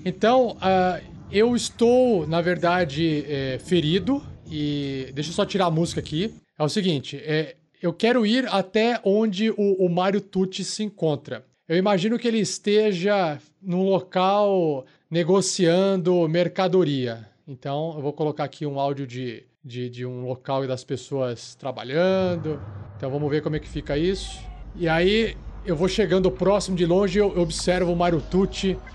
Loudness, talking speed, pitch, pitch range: -23 LUFS, 160 wpm, 175 Hz, 145-195 Hz